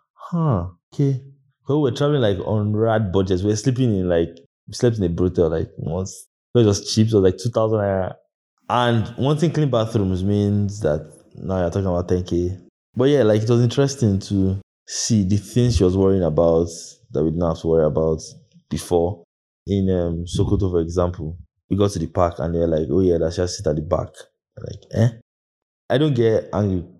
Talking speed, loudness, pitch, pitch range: 200 wpm, -20 LUFS, 95 Hz, 85-115 Hz